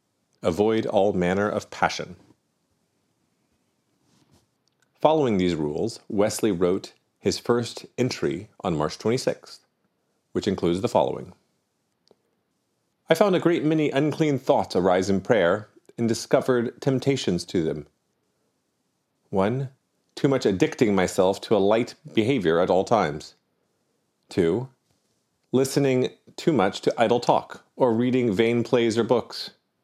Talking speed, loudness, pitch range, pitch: 120 wpm, -24 LUFS, 105-135 Hz, 120 Hz